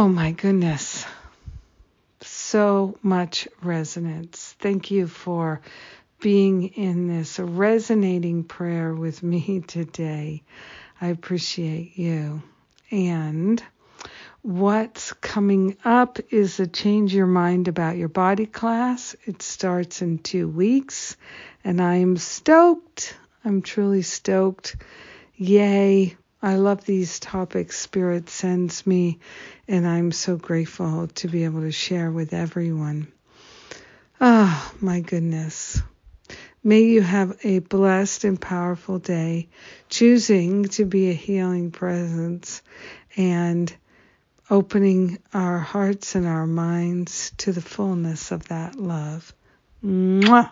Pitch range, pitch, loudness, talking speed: 170-200 Hz, 180 Hz, -22 LUFS, 115 wpm